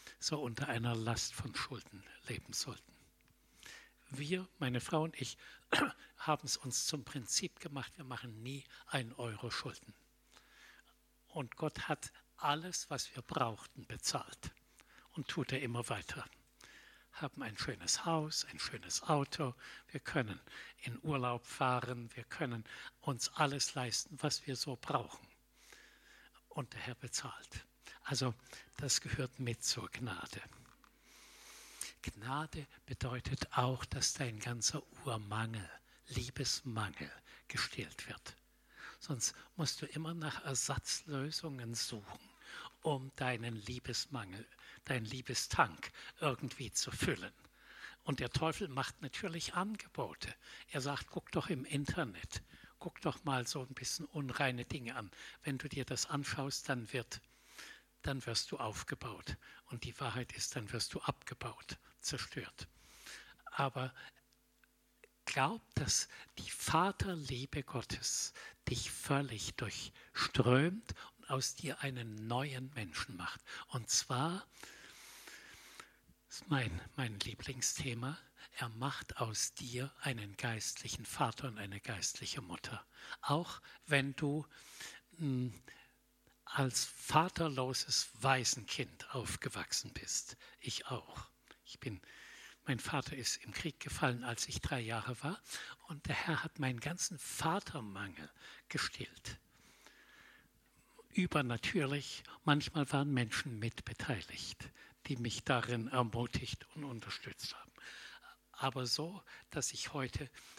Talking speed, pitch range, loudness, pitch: 120 wpm, 120-145 Hz, -39 LUFS, 130 Hz